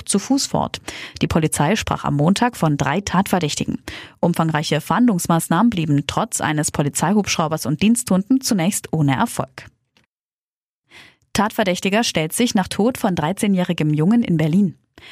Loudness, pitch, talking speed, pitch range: -19 LUFS, 180 Hz, 125 wpm, 155-210 Hz